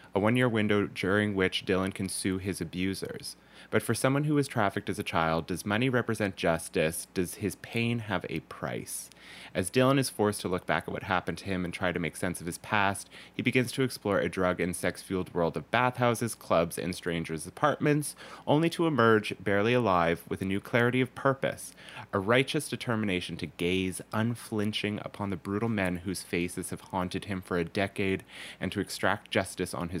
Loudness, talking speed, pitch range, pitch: -30 LUFS, 200 wpm, 90-115 Hz, 100 Hz